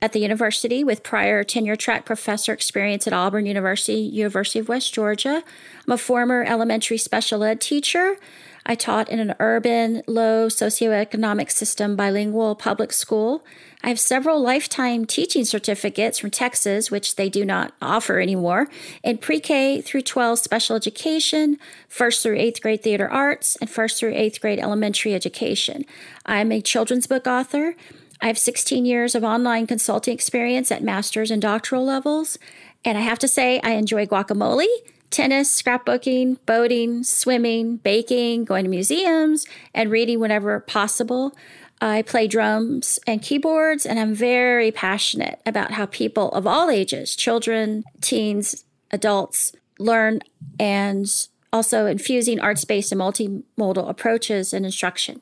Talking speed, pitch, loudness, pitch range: 145 wpm, 230 Hz, -20 LUFS, 215-250 Hz